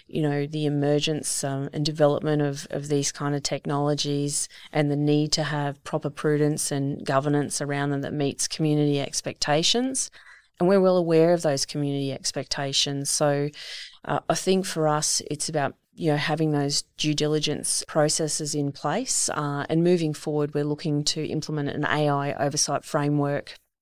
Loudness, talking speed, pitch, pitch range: -25 LUFS, 165 wpm, 150 Hz, 145-155 Hz